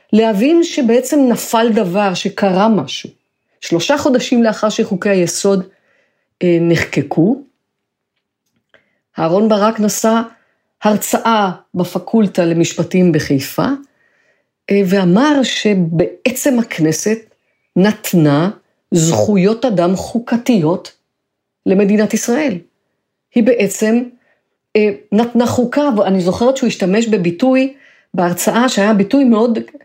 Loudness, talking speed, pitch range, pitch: -14 LUFS, 80 wpm, 185-245 Hz, 215 Hz